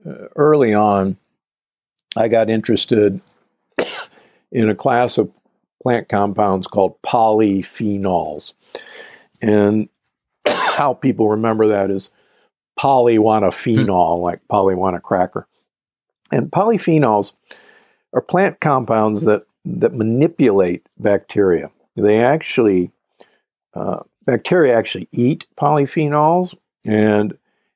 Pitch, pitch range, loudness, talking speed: 110 Hz, 105-135 Hz, -17 LUFS, 90 wpm